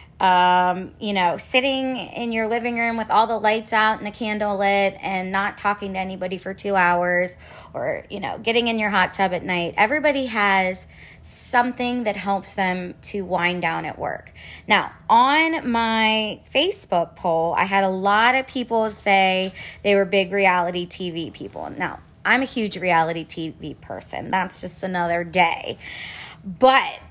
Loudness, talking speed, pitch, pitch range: -21 LUFS, 170 wpm, 195 Hz, 180-225 Hz